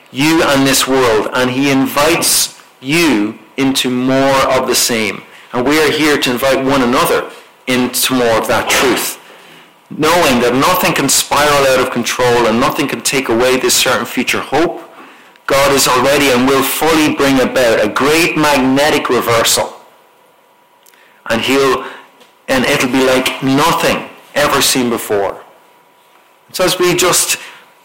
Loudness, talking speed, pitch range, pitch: -12 LUFS, 150 wpm, 130-170 Hz, 135 Hz